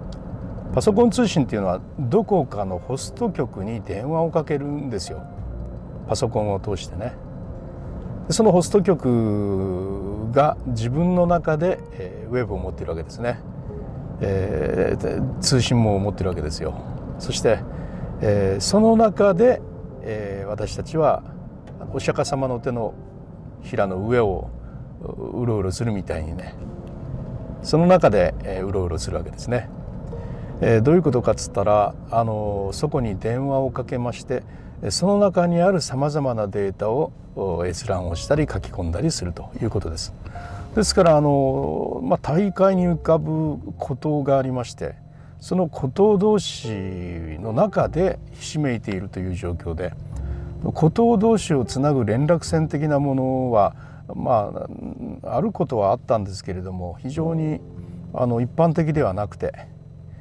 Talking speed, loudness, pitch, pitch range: 280 characters per minute, -22 LUFS, 125 Hz, 100-155 Hz